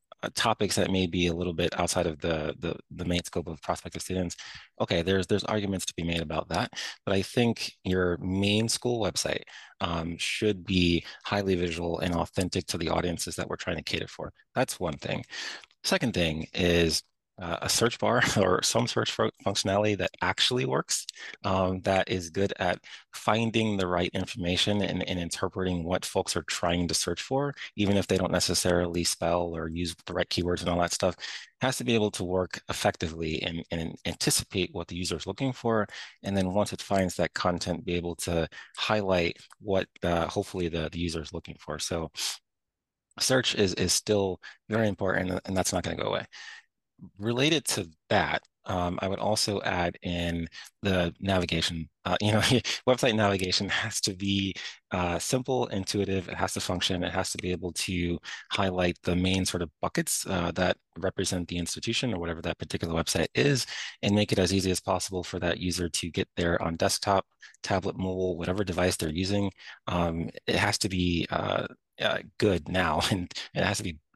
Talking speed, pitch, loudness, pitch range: 190 wpm, 90 Hz, -28 LUFS, 85-100 Hz